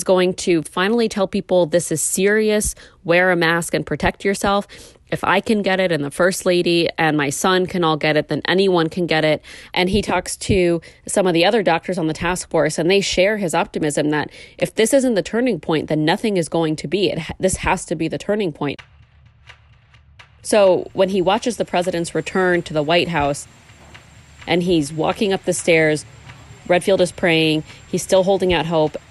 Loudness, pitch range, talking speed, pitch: -18 LUFS, 160-190 Hz, 205 wpm, 175 Hz